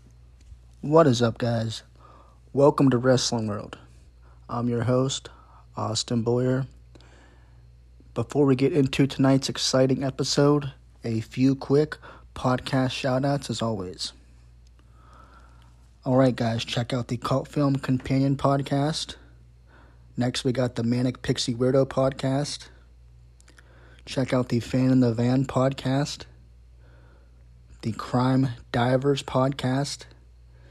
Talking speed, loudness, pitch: 115 wpm, -24 LUFS, 120 Hz